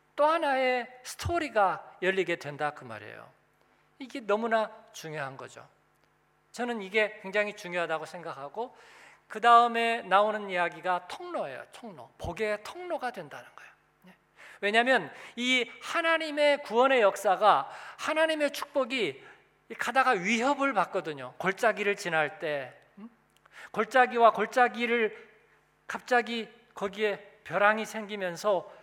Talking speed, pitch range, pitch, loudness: 275 characters per minute, 190-260 Hz, 220 Hz, -28 LUFS